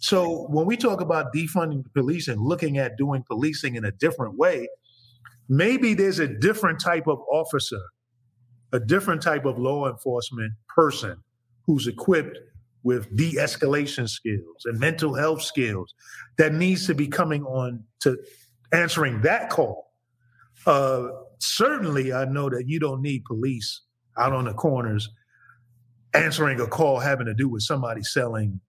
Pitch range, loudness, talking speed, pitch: 120-155 Hz, -24 LUFS, 155 wpm, 130 Hz